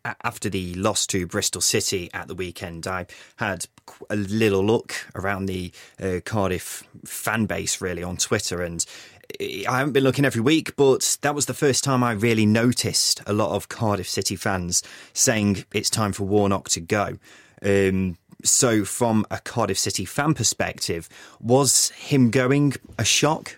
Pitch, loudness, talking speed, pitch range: 105 Hz, -22 LUFS, 165 wpm, 95-125 Hz